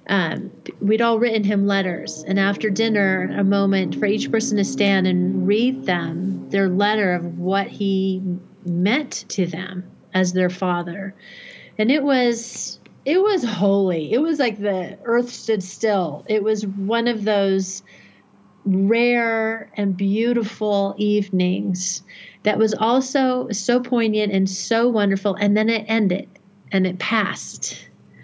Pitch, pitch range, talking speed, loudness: 205 Hz, 190-225 Hz, 140 wpm, -21 LUFS